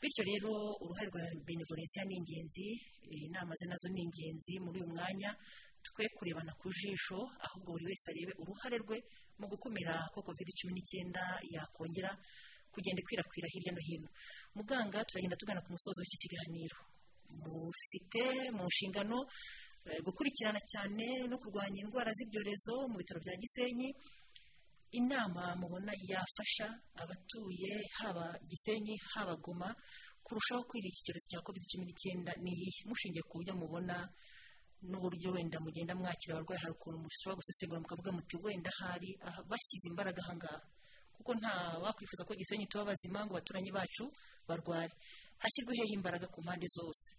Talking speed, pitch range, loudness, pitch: 140 wpm, 175-210 Hz, -42 LUFS, 185 Hz